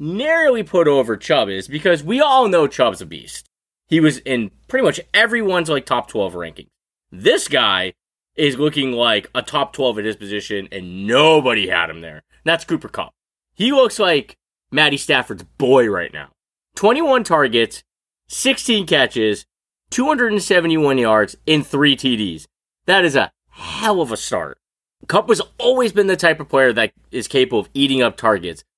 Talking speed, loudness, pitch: 165 wpm, -17 LUFS, 150 Hz